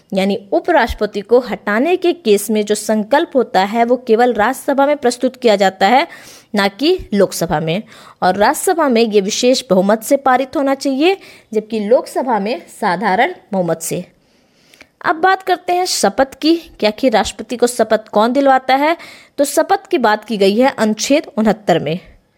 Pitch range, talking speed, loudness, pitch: 210-290 Hz, 170 wpm, -15 LUFS, 245 Hz